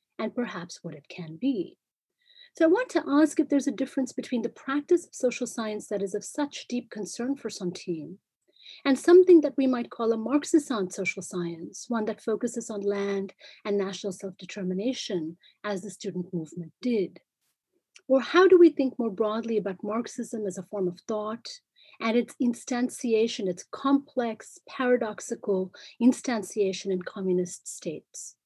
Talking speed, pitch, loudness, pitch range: 160 wpm, 225 Hz, -27 LUFS, 195-270 Hz